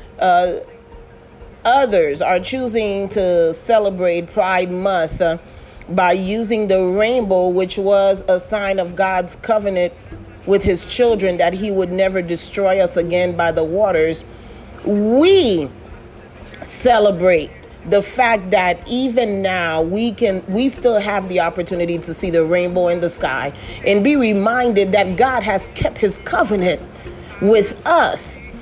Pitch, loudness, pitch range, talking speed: 190 Hz, -16 LUFS, 175-215 Hz, 135 wpm